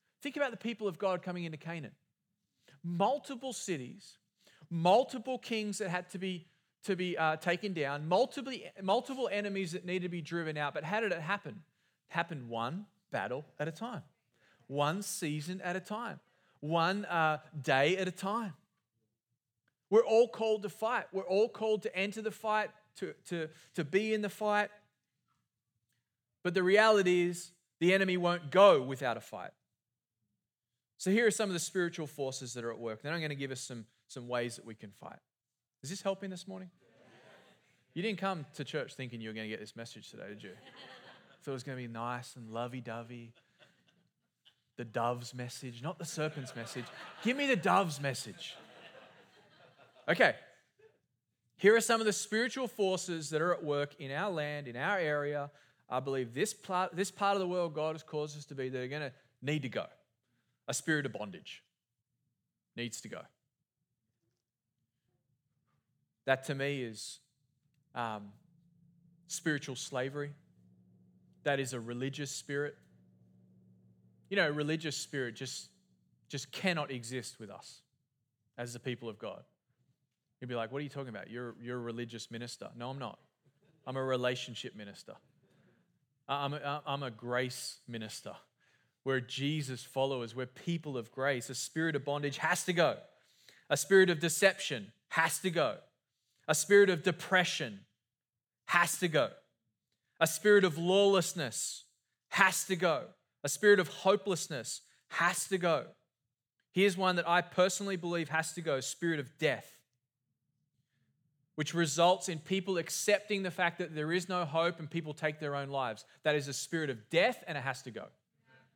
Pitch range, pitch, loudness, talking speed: 125-185 Hz, 150 Hz, -34 LUFS, 170 wpm